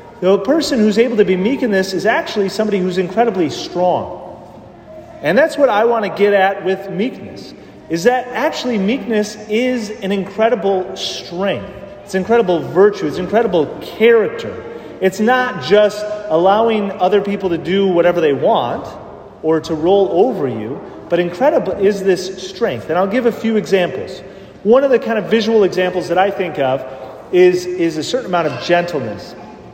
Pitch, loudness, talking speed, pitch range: 195 Hz, -15 LUFS, 170 wpm, 185-230 Hz